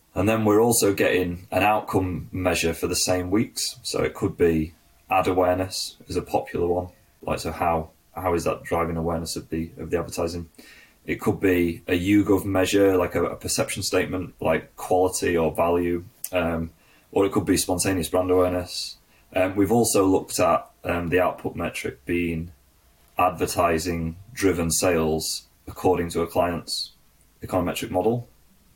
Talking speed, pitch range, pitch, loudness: 160 wpm, 85-95 Hz, 90 Hz, -24 LUFS